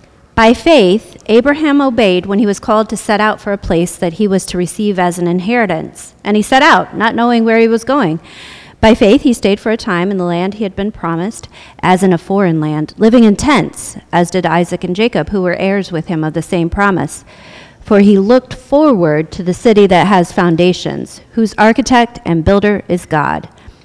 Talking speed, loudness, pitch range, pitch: 210 wpm, -12 LUFS, 175-225 Hz, 200 Hz